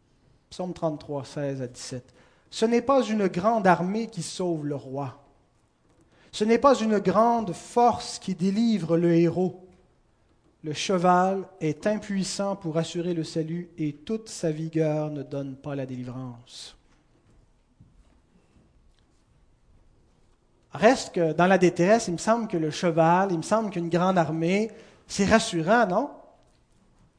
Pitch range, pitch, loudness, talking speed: 155-200 Hz, 175 Hz, -25 LUFS, 135 wpm